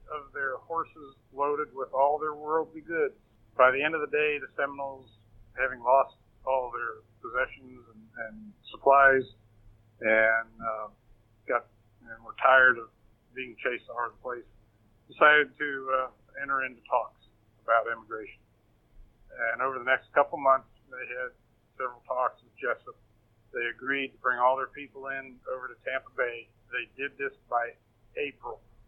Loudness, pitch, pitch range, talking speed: -28 LUFS, 130 Hz, 115-140 Hz, 155 wpm